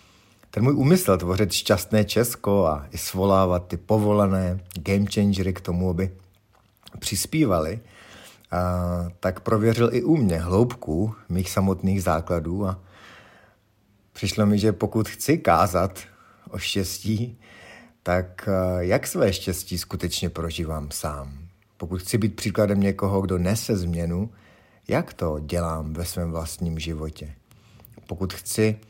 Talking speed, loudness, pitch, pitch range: 125 wpm, -24 LUFS, 95 Hz, 90-105 Hz